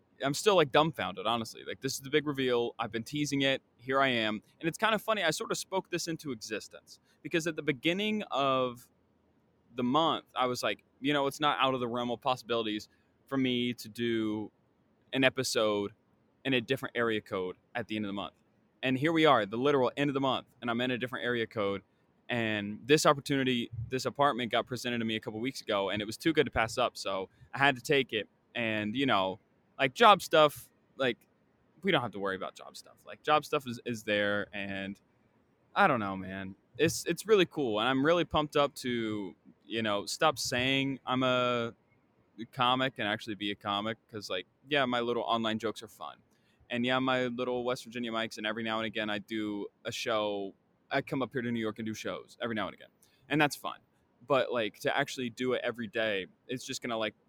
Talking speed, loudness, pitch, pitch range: 225 wpm, -31 LUFS, 120 Hz, 110-135 Hz